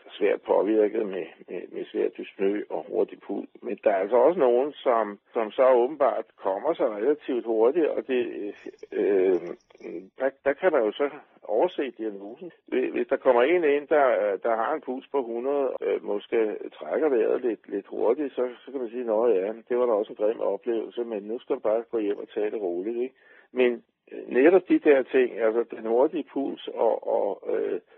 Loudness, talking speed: -26 LUFS, 200 wpm